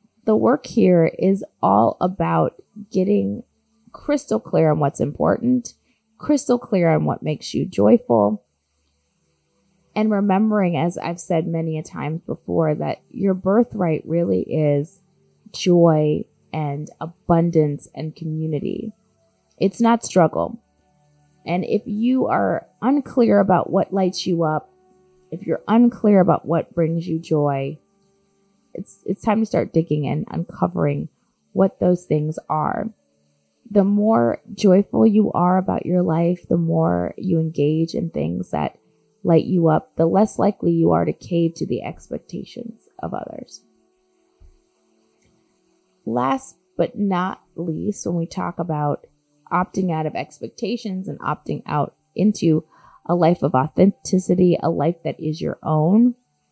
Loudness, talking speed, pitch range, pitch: -20 LUFS, 135 wpm, 155-205 Hz, 175 Hz